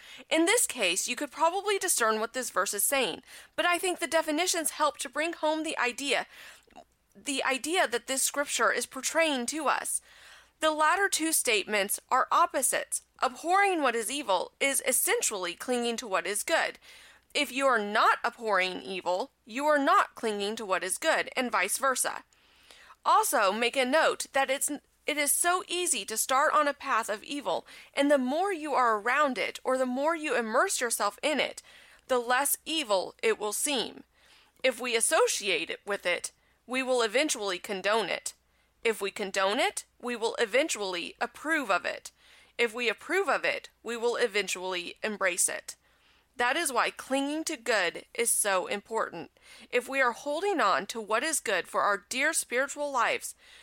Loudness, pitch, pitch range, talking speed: -28 LUFS, 265 Hz, 225-310 Hz, 175 wpm